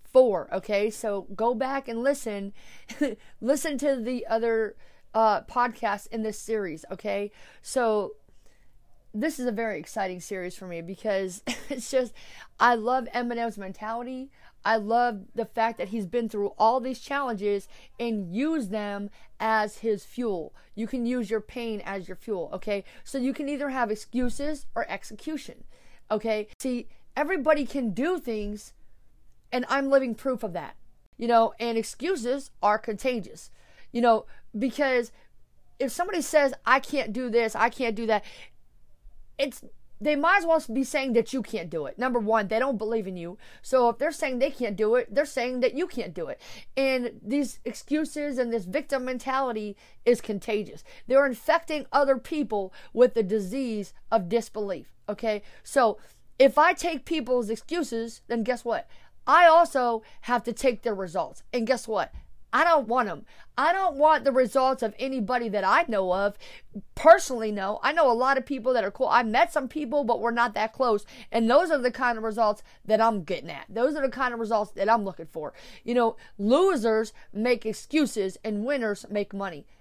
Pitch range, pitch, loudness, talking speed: 215-270 Hz, 235 Hz, -26 LUFS, 175 wpm